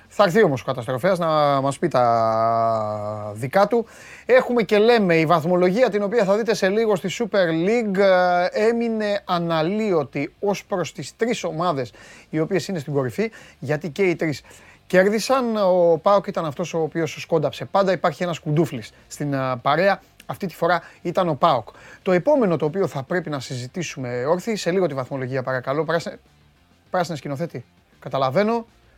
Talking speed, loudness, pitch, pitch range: 160 wpm, -21 LUFS, 170 Hz, 135-195 Hz